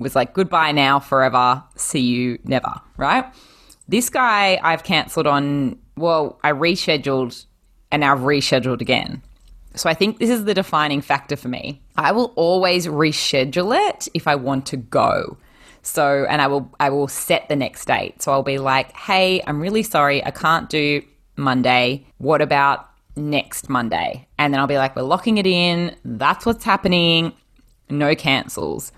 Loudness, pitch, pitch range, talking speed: -19 LUFS, 145 Hz, 135-170 Hz, 170 wpm